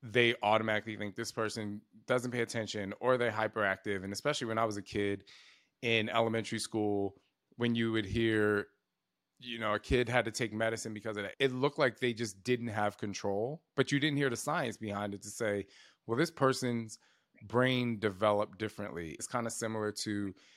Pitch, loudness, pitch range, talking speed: 110 Hz, -34 LUFS, 105-120 Hz, 190 wpm